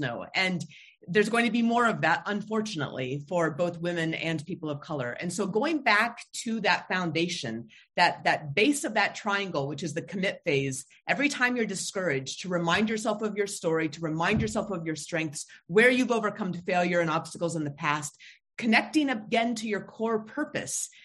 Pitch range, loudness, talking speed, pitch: 160-220 Hz, -28 LUFS, 190 wpm, 185 Hz